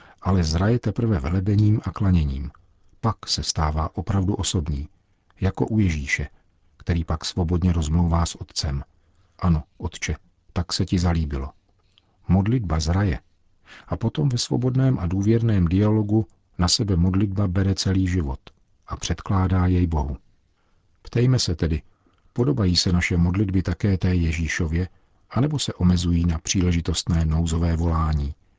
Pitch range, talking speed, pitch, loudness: 85-100 Hz, 130 wpm, 90 Hz, -23 LUFS